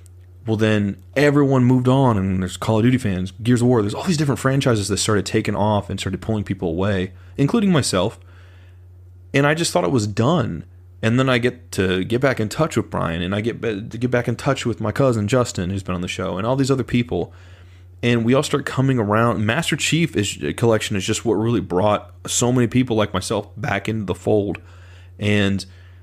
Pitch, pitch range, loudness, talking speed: 105 Hz, 90-125 Hz, -20 LUFS, 220 wpm